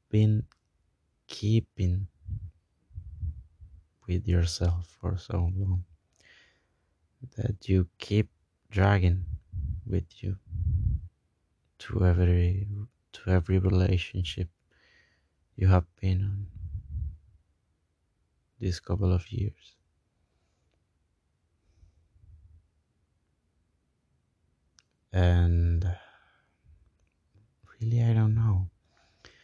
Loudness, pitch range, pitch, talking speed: -29 LUFS, 85-95 Hz, 90 Hz, 65 wpm